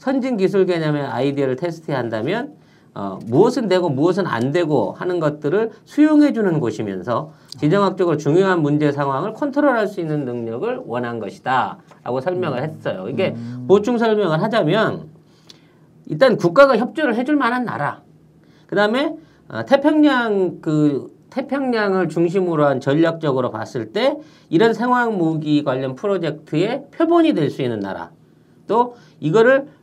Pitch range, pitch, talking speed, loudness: 150-245 Hz, 180 Hz, 315 characters per minute, -19 LUFS